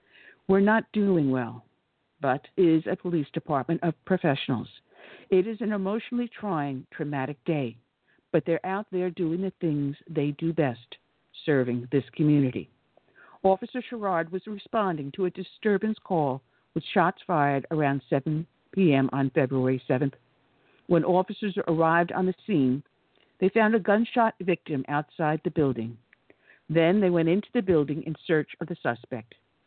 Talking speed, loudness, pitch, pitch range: 150 wpm, -27 LUFS, 165 Hz, 140-185 Hz